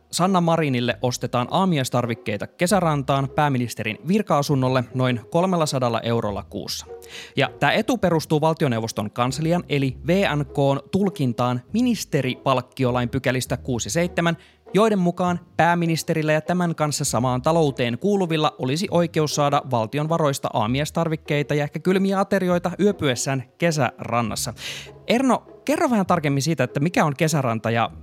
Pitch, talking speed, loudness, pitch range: 145 Hz, 115 wpm, -22 LUFS, 125-170 Hz